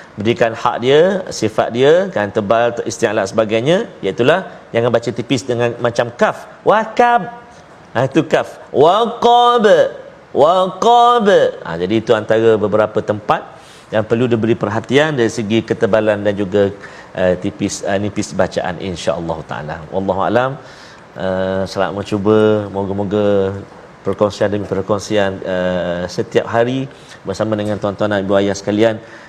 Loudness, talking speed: -15 LUFS, 135 wpm